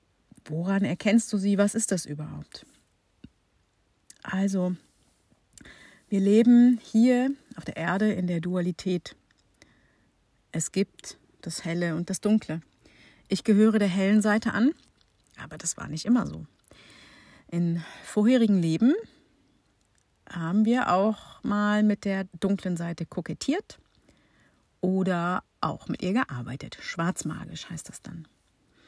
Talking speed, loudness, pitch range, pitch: 125 wpm, -26 LUFS, 165-215 Hz, 190 Hz